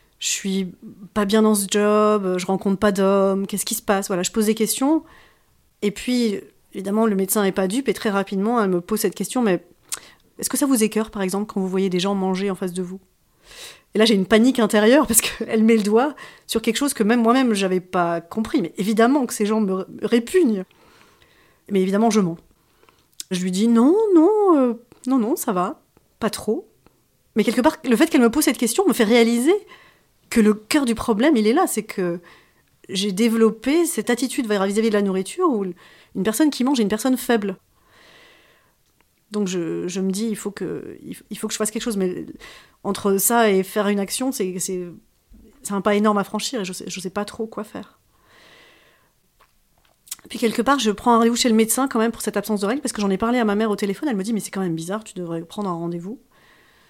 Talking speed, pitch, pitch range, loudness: 230 wpm, 215 Hz, 195-235 Hz, -20 LUFS